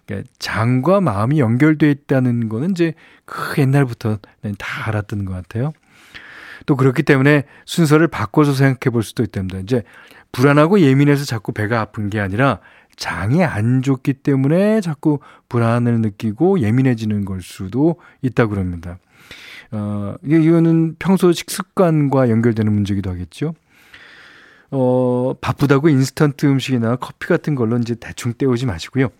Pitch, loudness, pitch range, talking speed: 130 Hz, -17 LUFS, 110-150 Hz, 320 characters per minute